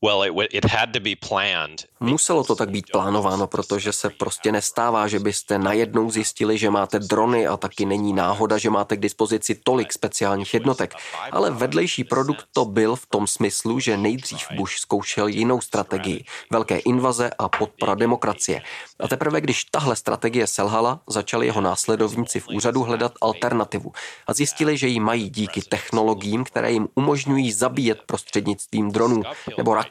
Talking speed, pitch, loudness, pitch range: 150 wpm, 110 Hz, -22 LUFS, 105-120 Hz